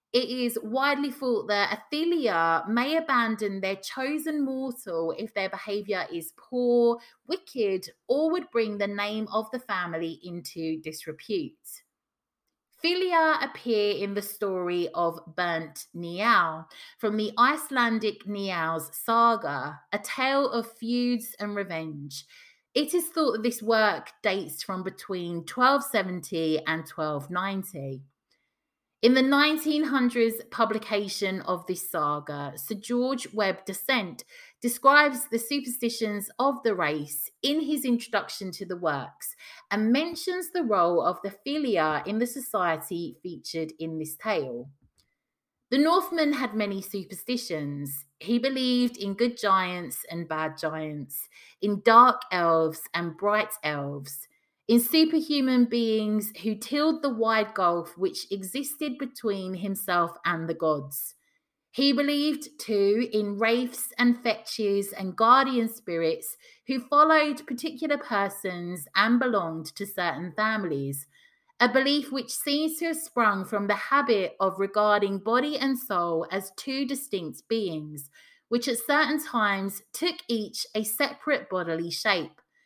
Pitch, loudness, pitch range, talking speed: 215 Hz, -27 LUFS, 180-260 Hz, 130 wpm